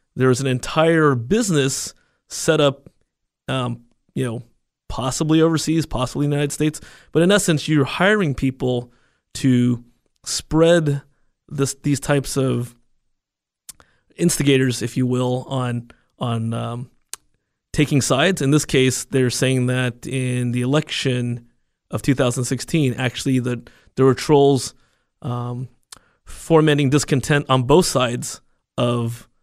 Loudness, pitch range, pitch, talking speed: -19 LUFS, 125-145 Hz, 130 Hz, 120 wpm